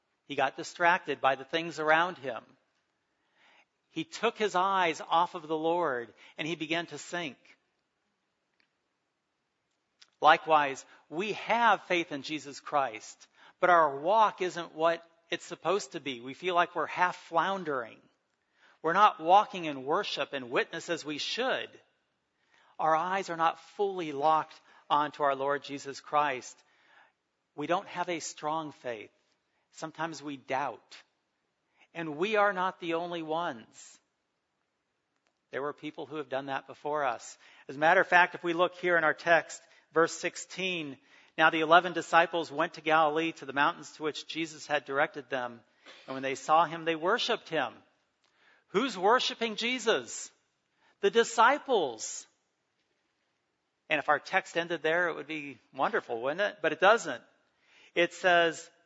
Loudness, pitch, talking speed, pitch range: -29 LUFS, 165 Hz, 150 wpm, 150-175 Hz